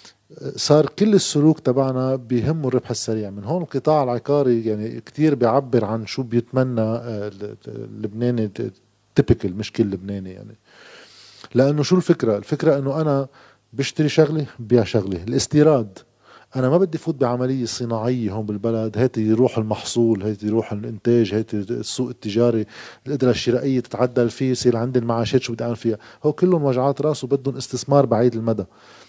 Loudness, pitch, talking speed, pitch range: -20 LUFS, 120 Hz, 145 wpm, 110-135 Hz